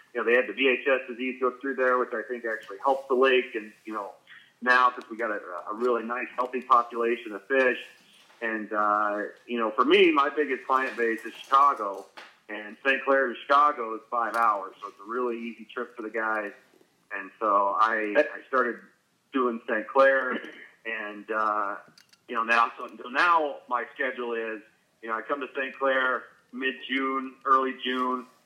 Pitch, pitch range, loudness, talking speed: 125 Hz, 110-130 Hz, -26 LUFS, 190 wpm